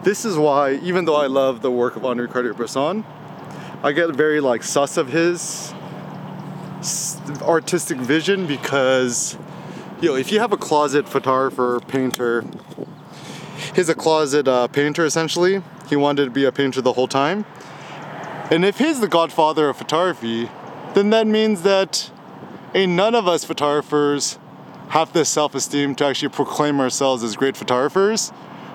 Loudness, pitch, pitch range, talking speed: -19 LUFS, 150 Hz, 135-175 Hz, 150 wpm